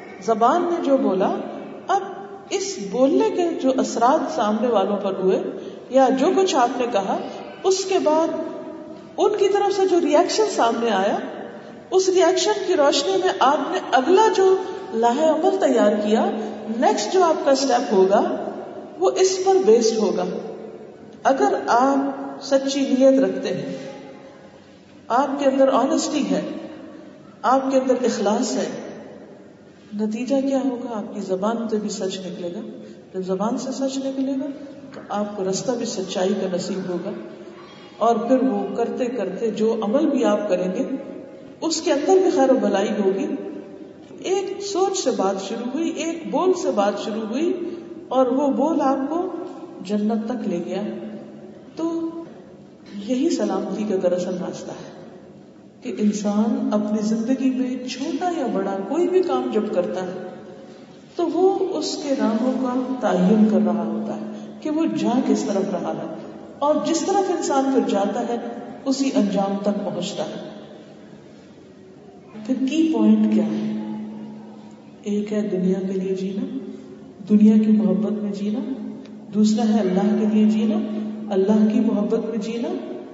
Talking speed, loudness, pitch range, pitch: 155 wpm, -21 LUFS, 210-315 Hz, 250 Hz